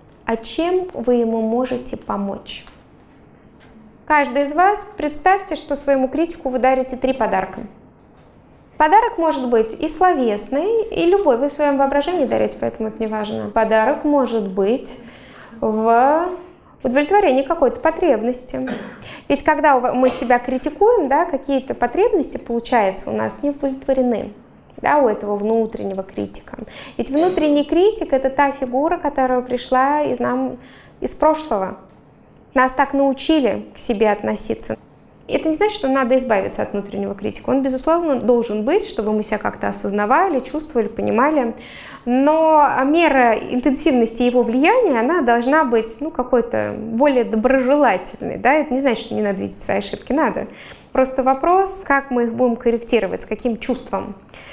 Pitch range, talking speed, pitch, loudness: 230-300 Hz, 145 wpm, 260 Hz, -18 LUFS